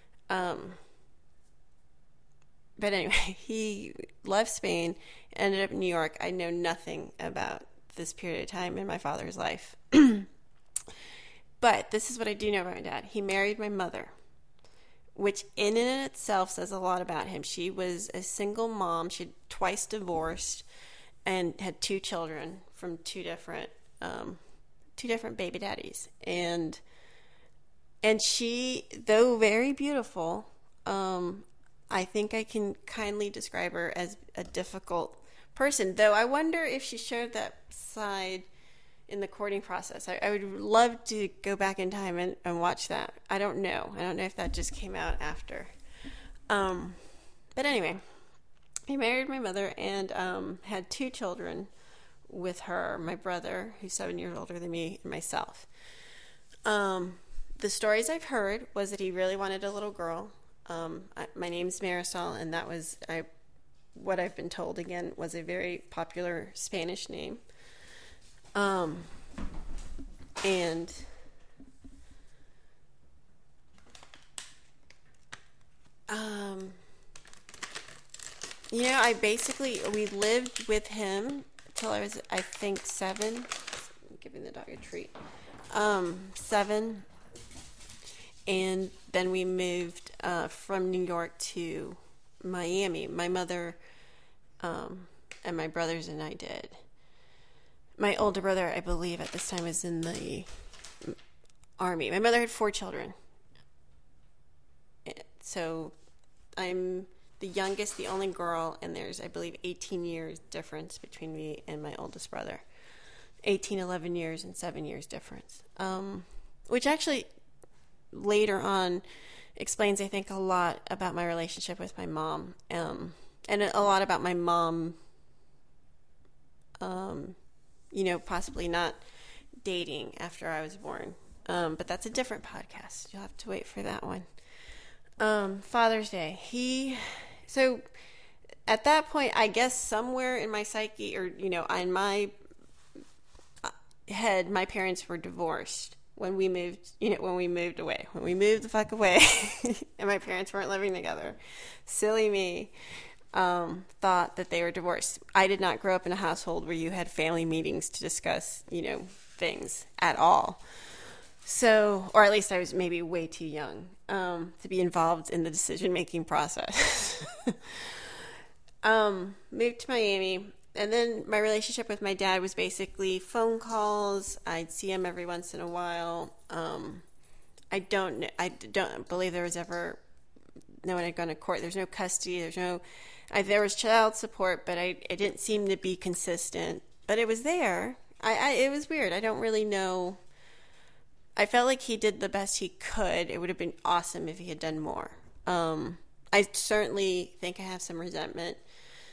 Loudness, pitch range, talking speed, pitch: -31 LUFS, 175-210 Hz, 150 wpm, 190 Hz